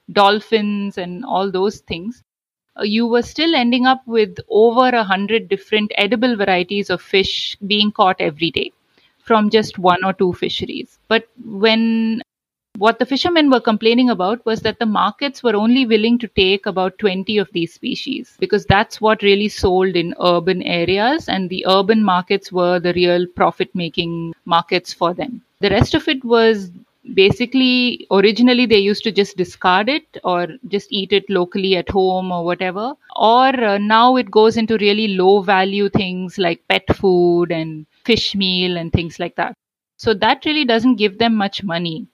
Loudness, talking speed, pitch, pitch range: -16 LUFS, 170 wpm, 205 Hz, 185-230 Hz